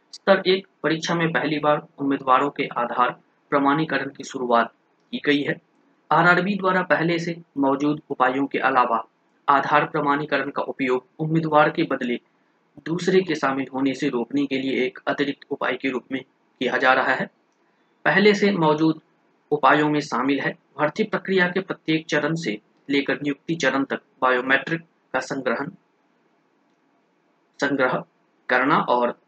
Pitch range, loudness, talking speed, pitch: 135-160 Hz, -22 LUFS, 140 wpm, 145 Hz